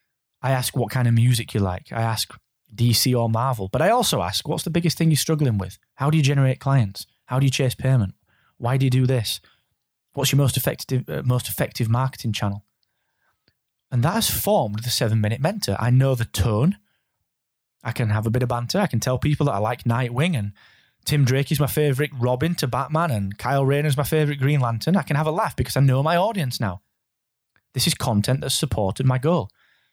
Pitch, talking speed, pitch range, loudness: 130 Hz, 220 wpm, 115-145 Hz, -22 LUFS